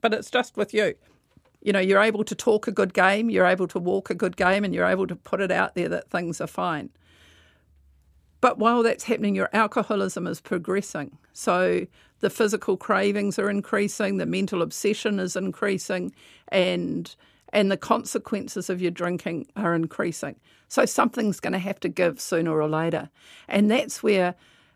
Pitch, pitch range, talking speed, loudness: 195 Hz, 175-215 Hz, 180 wpm, -24 LUFS